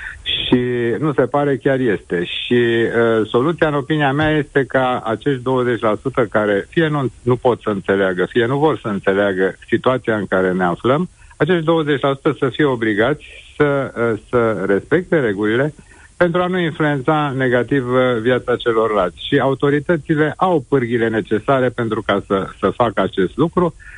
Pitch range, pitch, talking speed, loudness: 110-145 Hz, 125 Hz, 155 wpm, -17 LUFS